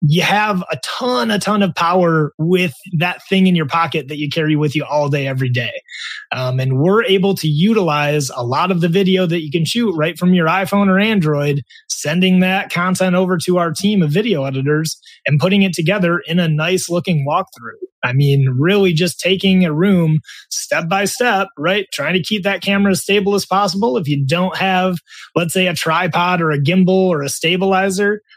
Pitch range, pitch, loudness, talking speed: 155-195 Hz, 180 Hz, -15 LUFS, 205 wpm